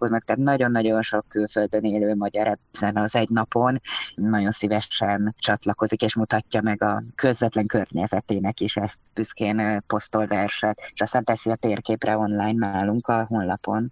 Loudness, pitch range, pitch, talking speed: -23 LUFS, 105-110 Hz, 110 Hz, 140 wpm